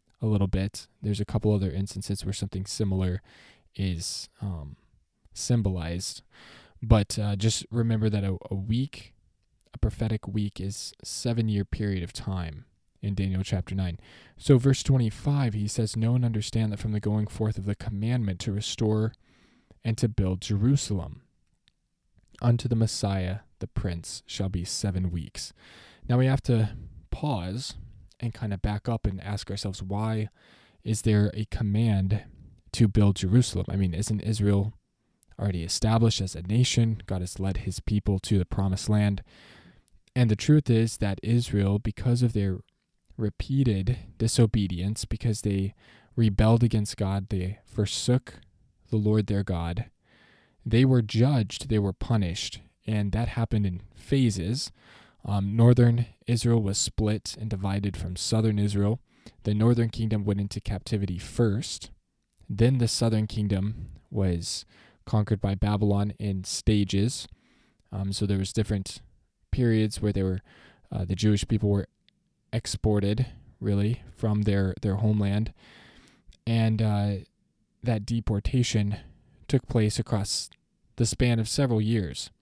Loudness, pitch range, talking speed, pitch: -27 LUFS, 95-115 Hz, 140 wpm, 105 Hz